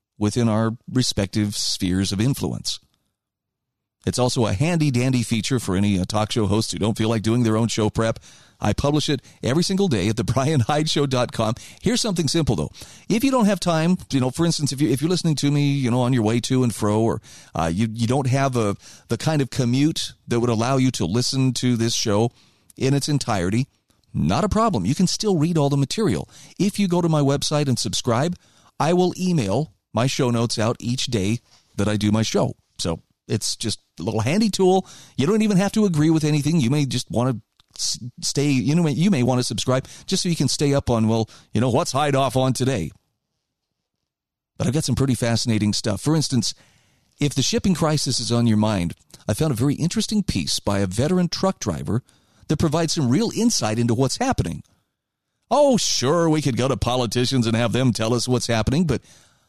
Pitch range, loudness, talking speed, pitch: 115-155 Hz, -21 LUFS, 215 wpm, 130 Hz